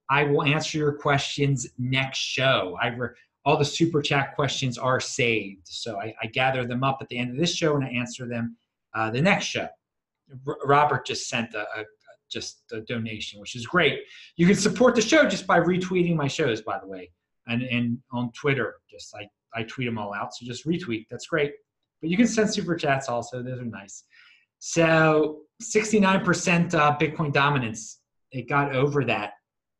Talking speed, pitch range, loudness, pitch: 195 wpm, 120-160 Hz, -24 LUFS, 135 Hz